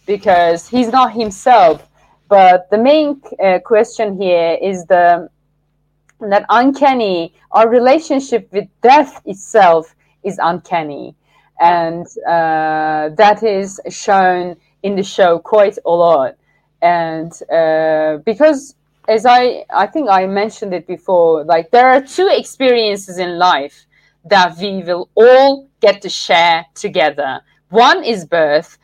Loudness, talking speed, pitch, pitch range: -13 LUFS, 125 wpm, 190 Hz, 165-225 Hz